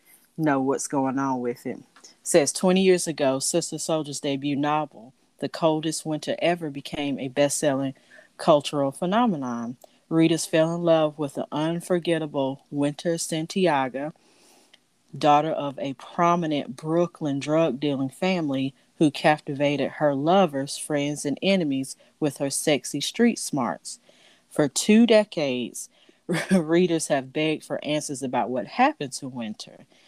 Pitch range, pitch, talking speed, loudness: 140-165 Hz, 150 Hz, 130 wpm, -24 LUFS